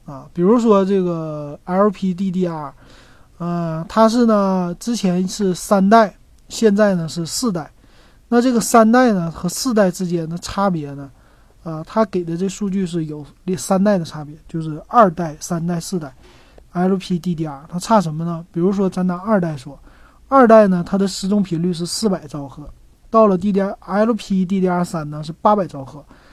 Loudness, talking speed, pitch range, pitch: -18 LUFS, 255 characters per minute, 165-205 Hz, 185 Hz